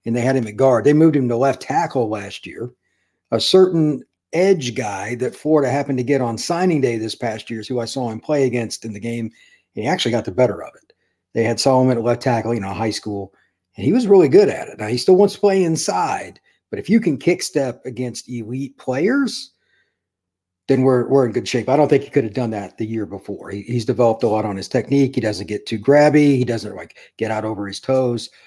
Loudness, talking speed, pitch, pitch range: -18 LUFS, 245 wpm, 125 Hz, 110-140 Hz